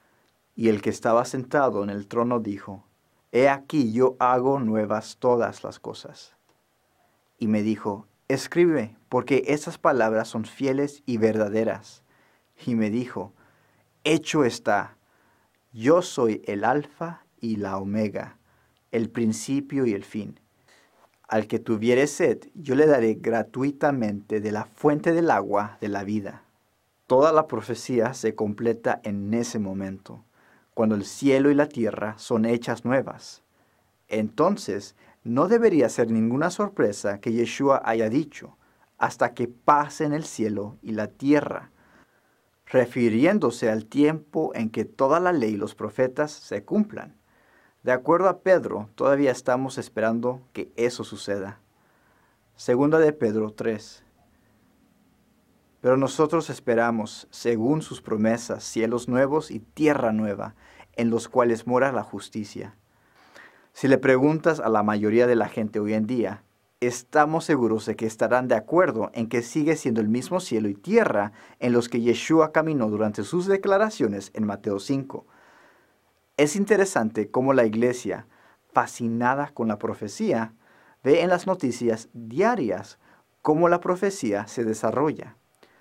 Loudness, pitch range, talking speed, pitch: -24 LUFS, 110-140 Hz, 140 wpm, 120 Hz